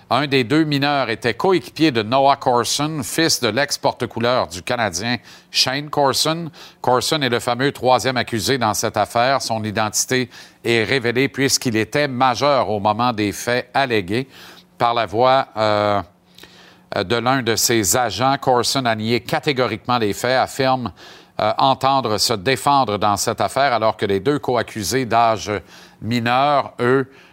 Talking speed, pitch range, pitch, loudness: 150 wpm, 110-135 Hz, 125 Hz, -18 LUFS